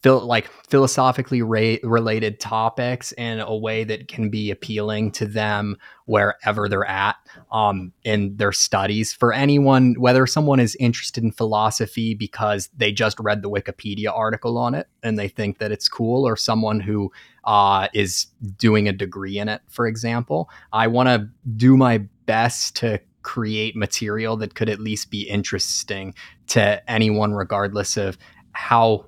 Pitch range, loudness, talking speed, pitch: 105-120 Hz, -21 LUFS, 155 wpm, 110 Hz